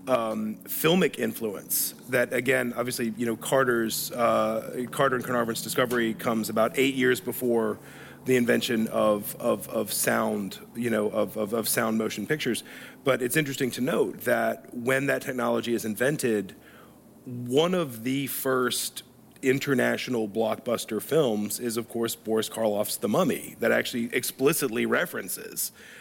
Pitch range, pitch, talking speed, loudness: 110-130 Hz, 120 Hz, 145 wpm, -26 LUFS